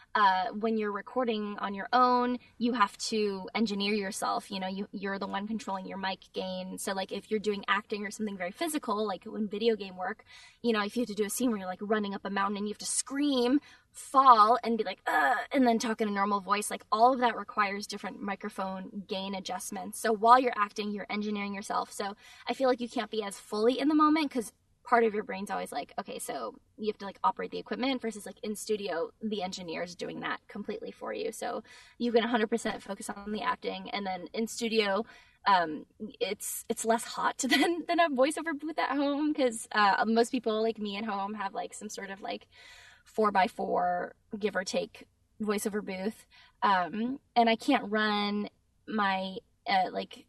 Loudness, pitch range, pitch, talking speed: -30 LUFS, 205-245 Hz, 225 Hz, 210 wpm